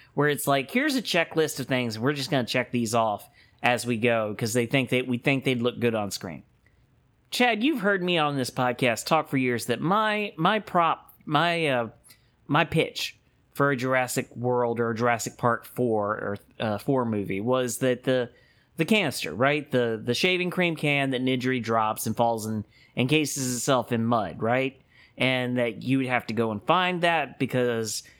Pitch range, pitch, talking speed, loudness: 120-145 Hz, 125 Hz, 200 wpm, -25 LUFS